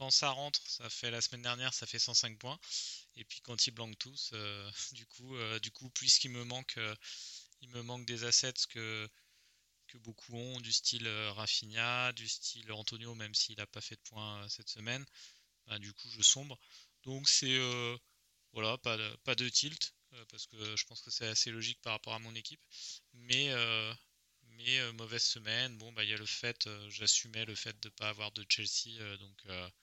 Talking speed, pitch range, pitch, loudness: 215 wpm, 110-125 Hz, 115 Hz, -35 LUFS